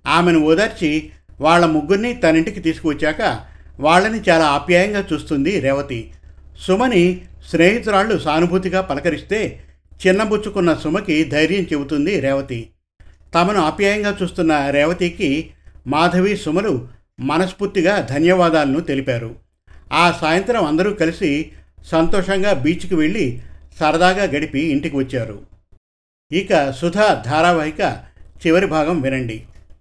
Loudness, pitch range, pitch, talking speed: -17 LUFS, 135-185 Hz, 160 Hz, 95 wpm